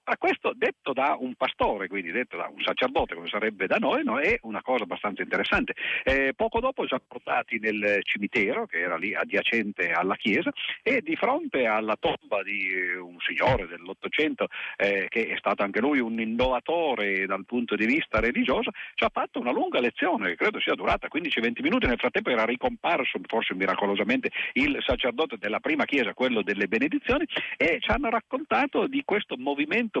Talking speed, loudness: 180 wpm, -26 LUFS